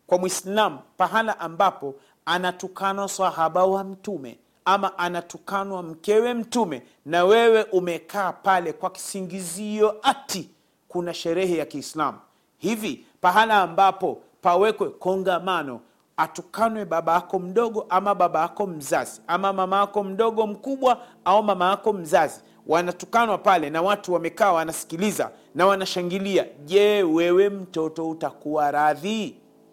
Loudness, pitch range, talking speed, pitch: -23 LUFS, 175-205 Hz, 115 wpm, 190 Hz